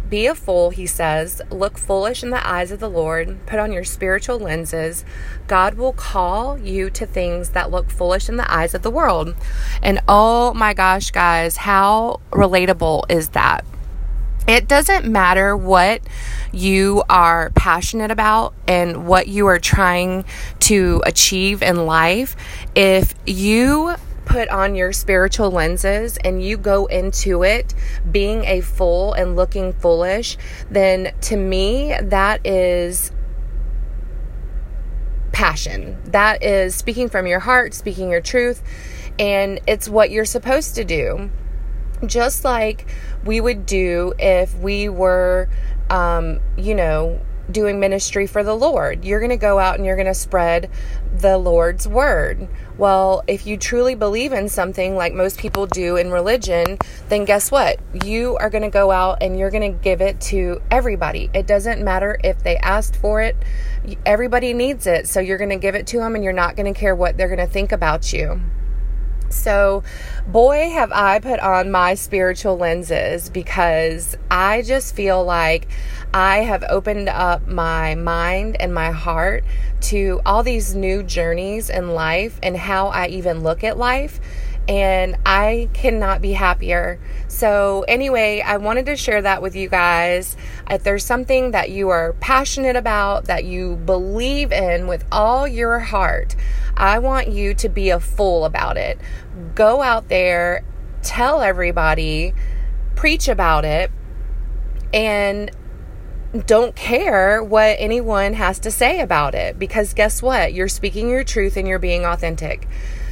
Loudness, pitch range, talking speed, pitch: -18 LUFS, 180-215 Hz, 155 wpm, 195 Hz